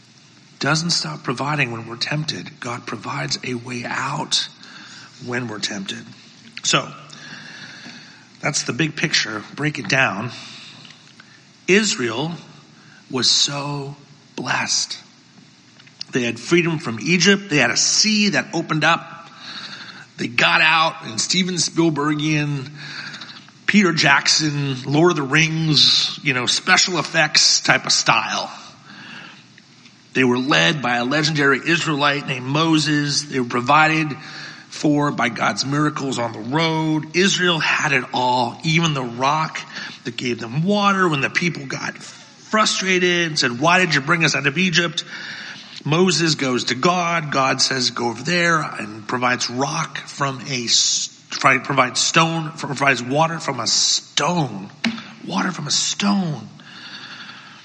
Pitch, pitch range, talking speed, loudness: 150 Hz, 130-170 Hz, 130 wpm, -18 LUFS